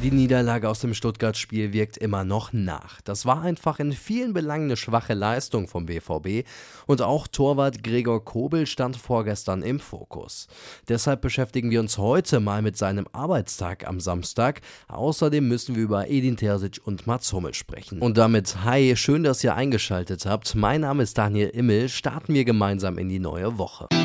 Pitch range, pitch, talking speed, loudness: 100-130 Hz, 115 Hz, 175 wpm, -24 LUFS